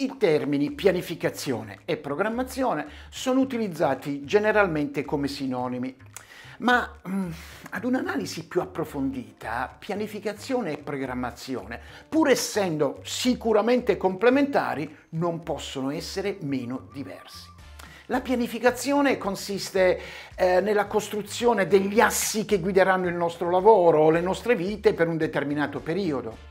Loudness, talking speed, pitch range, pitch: -25 LUFS, 110 wpm, 145-220 Hz, 185 Hz